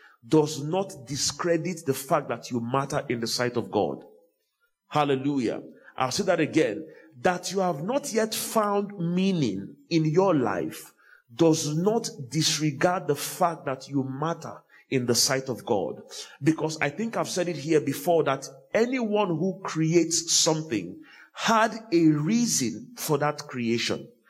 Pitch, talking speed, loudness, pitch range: 160 Hz, 150 wpm, -26 LUFS, 140-185 Hz